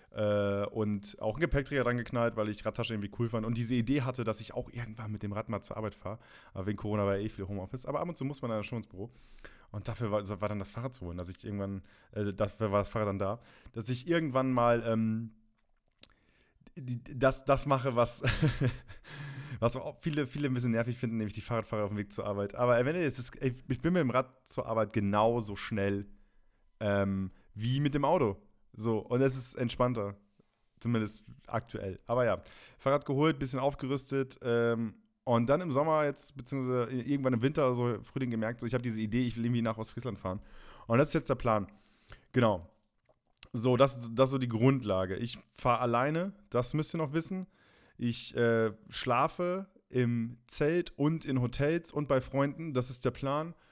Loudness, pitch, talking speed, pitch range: -32 LUFS, 120 Hz, 205 wpm, 110-135 Hz